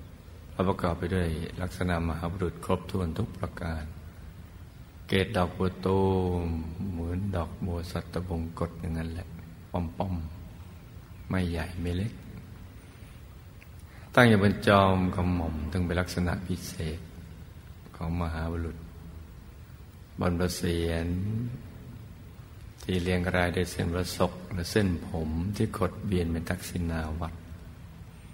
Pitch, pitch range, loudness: 90 Hz, 85-95 Hz, -30 LUFS